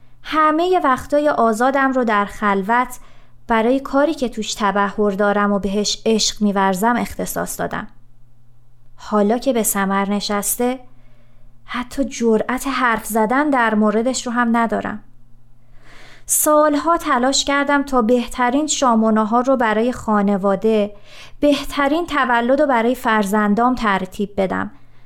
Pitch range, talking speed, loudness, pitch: 200-255 Hz, 115 wpm, -17 LUFS, 225 Hz